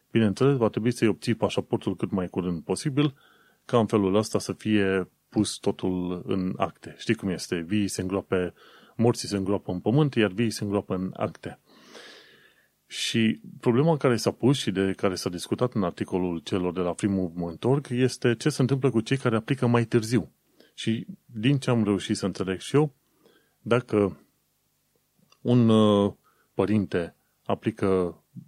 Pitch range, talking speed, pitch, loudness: 95-120 Hz, 160 wpm, 105 Hz, -26 LUFS